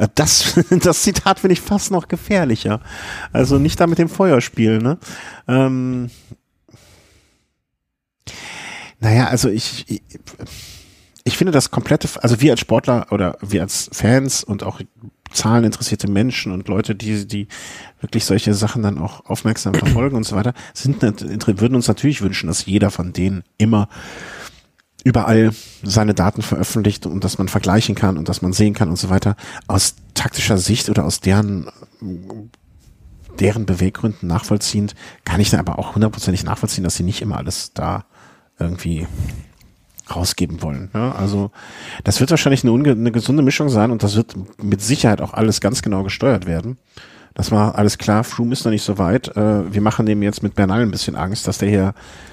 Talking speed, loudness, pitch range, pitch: 165 wpm, -17 LUFS, 95-120 Hz, 105 Hz